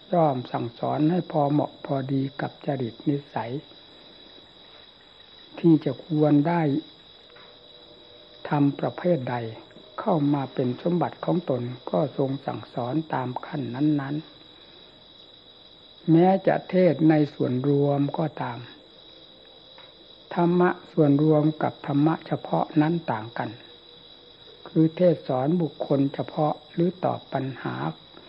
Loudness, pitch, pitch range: -25 LUFS, 145 Hz, 130-160 Hz